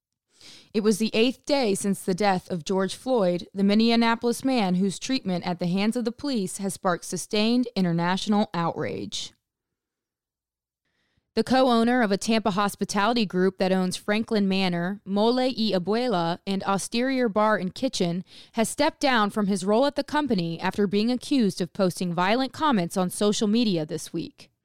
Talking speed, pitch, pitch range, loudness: 165 wpm, 205 Hz, 185-230 Hz, -25 LUFS